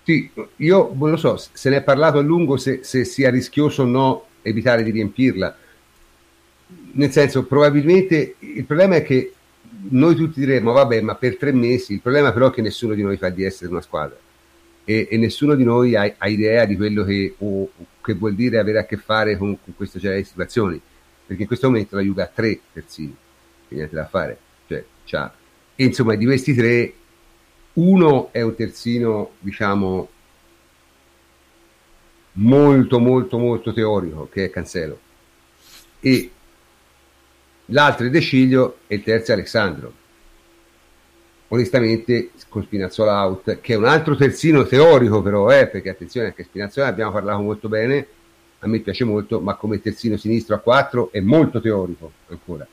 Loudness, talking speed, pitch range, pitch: -18 LUFS, 165 wpm, 85-130 Hz, 110 Hz